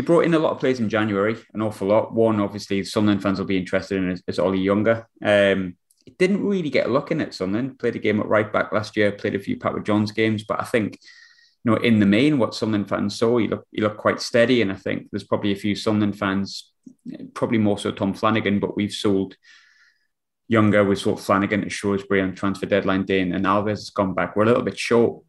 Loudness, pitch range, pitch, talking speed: -22 LUFS, 100-115 Hz, 105 Hz, 240 wpm